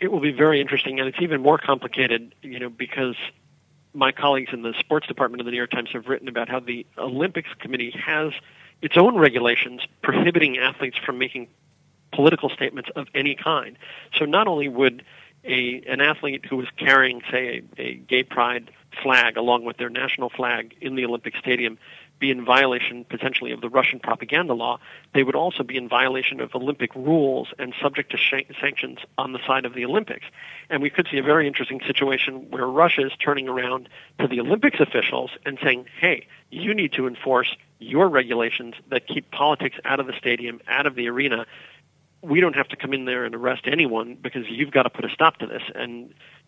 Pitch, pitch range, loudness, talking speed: 130 Hz, 125-145 Hz, -22 LUFS, 200 wpm